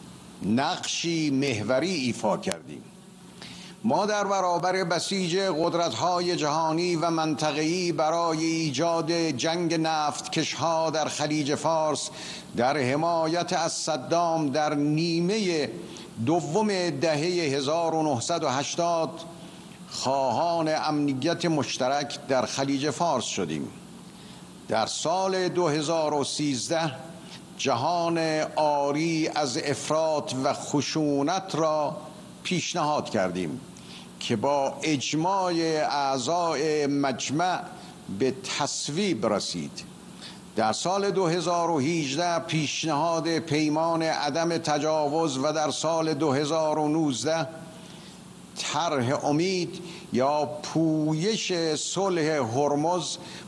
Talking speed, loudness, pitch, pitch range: 80 wpm, -26 LUFS, 160 Hz, 150-170 Hz